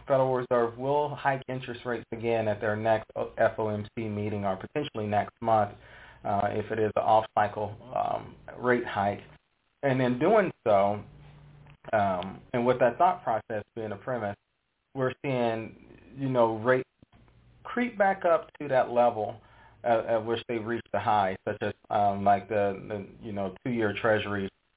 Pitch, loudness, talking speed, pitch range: 115 Hz, -28 LUFS, 160 wpm, 105-130 Hz